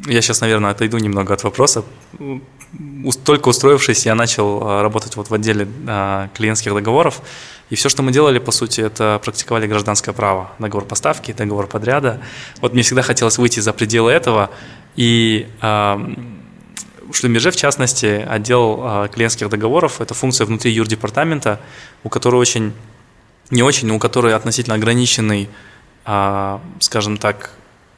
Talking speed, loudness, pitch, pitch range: 135 wpm, -15 LUFS, 115 Hz, 105-125 Hz